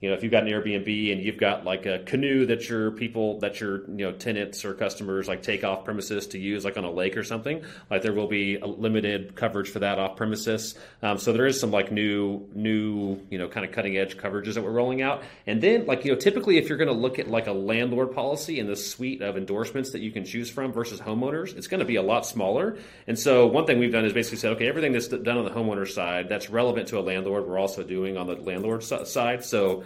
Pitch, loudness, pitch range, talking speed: 105 Hz, -26 LUFS, 100-115 Hz, 260 wpm